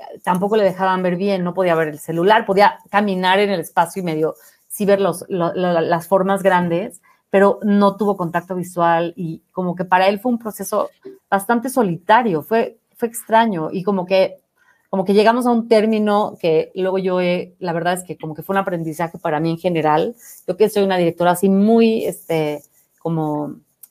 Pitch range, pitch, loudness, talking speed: 170-205 Hz, 190 Hz, -18 LUFS, 195 wpm